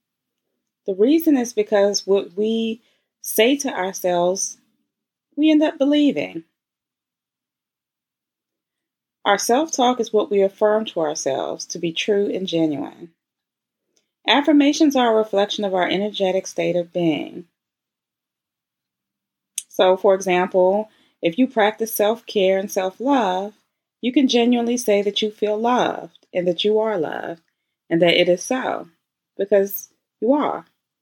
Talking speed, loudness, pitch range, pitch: 135 wpm, -20 LUFS, 185-240 Hz, 205 Hz